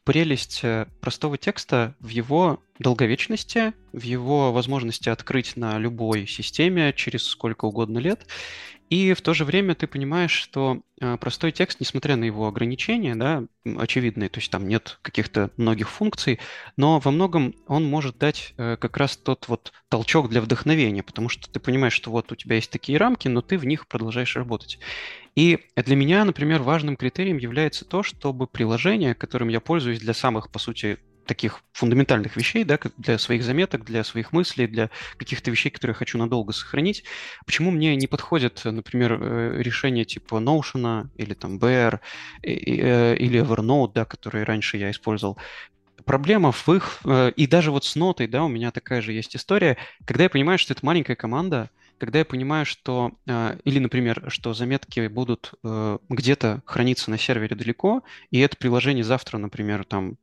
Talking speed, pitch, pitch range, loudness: 165 wpm, 125 Hz, 115-150 Hz, -23 LUFS